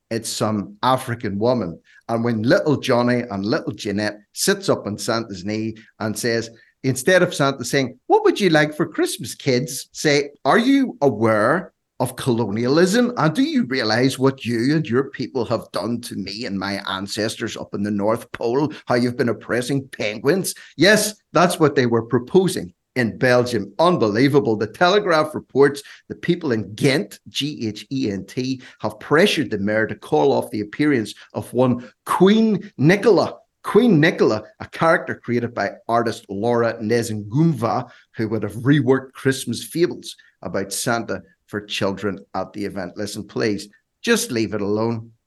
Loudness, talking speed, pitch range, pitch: -20 LUFS, 165 wpm, 105-140 Hz, 120 Hz